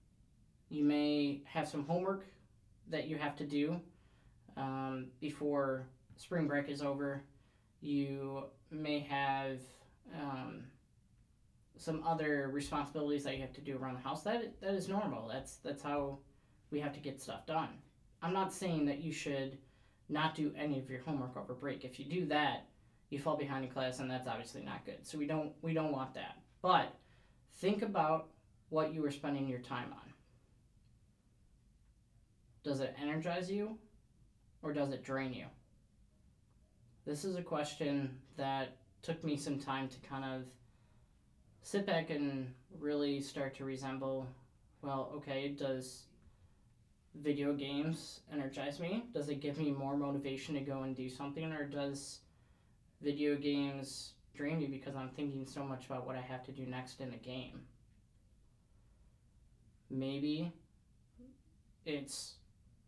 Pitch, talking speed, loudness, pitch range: 140 Hz, 150 wpm, -40 LUFS, 130-150 Hz